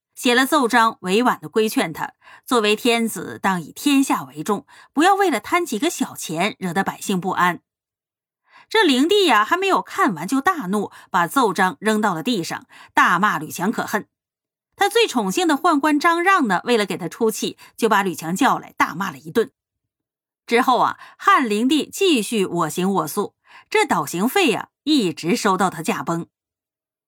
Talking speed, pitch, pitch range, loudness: 255 characters per minute, 230 Hz, 190-315 Hz, -19 LUFS